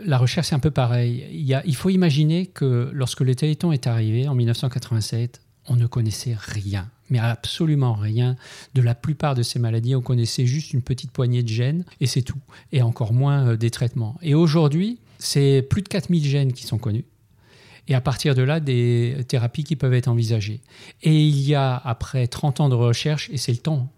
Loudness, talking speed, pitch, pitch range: -22 LUFS, 210 wpm, 130 Hz, 120-150 Hz